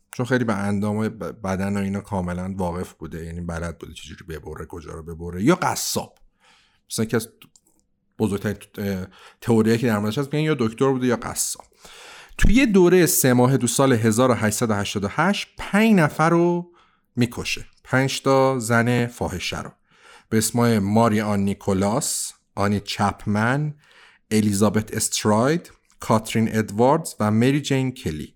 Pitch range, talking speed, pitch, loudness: 100-130 Hz, 135 wpm, 110 Hz, -21 LUFS